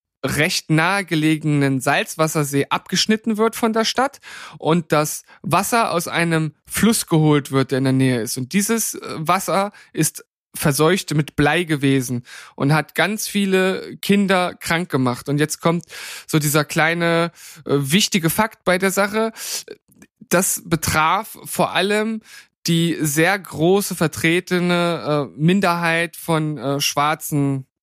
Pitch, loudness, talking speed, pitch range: 165 Hz, -19 LUFS, 130 wpm, 150-195 Hz